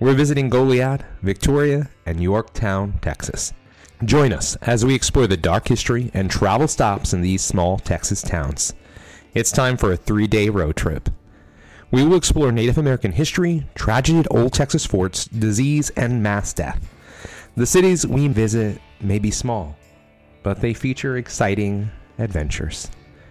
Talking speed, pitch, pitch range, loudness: 150 wpm, 110 Hz, 90-130 Hz, -19 LUFS